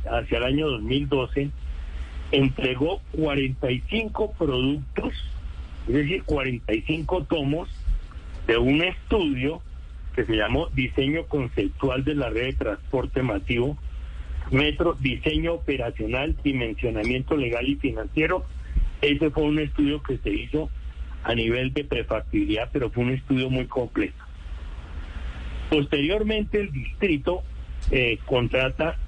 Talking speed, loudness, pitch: 110 wpm, -25 LUFS, 130 Hz